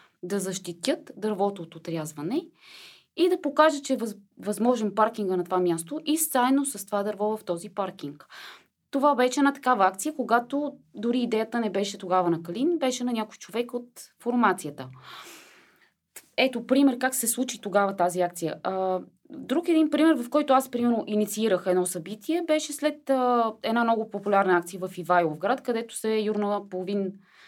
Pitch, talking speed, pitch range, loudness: 220 Hz, 160 wpm, 190-265 Hz, -26 LUFS